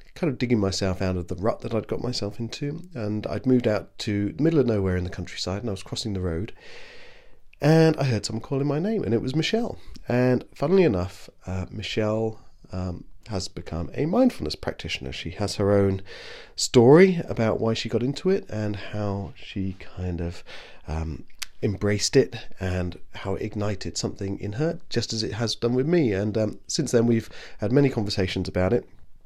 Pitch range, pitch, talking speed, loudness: 95-130 Hz, 105 Hz, 195 wpm, -25 LUFS